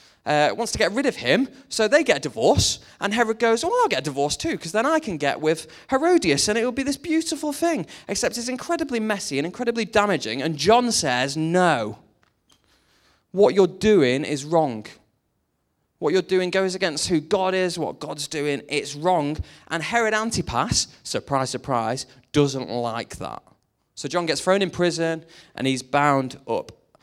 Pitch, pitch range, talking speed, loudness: 170 Hz, 145-220 Hz, 185 wpm, -22 LUFS